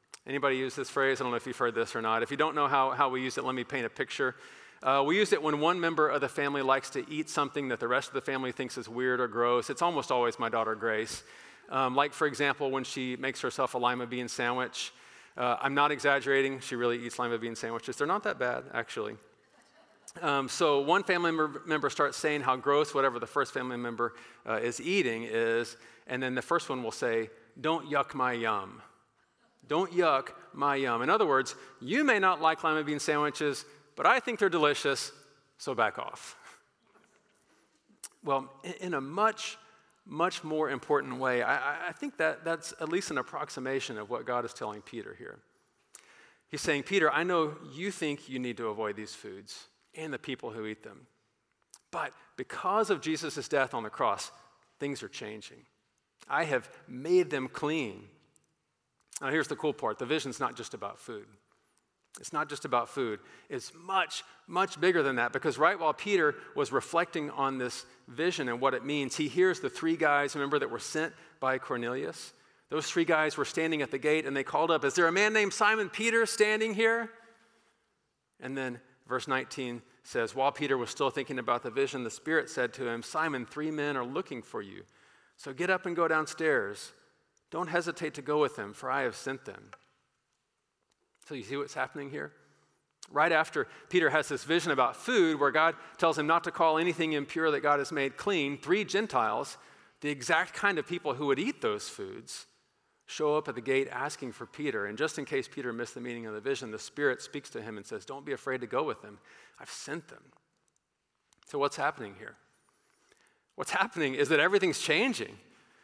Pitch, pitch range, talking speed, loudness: 145 Hz, 130-165 Hz, 200 wpm, -31 LUFS